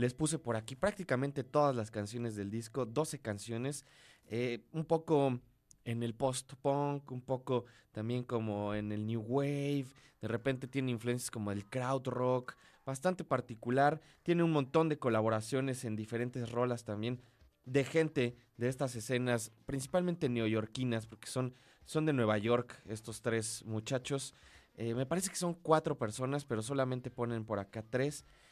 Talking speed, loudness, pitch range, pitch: 155 wpm, -36 LUFS, 115-140 Hz, 125 Hz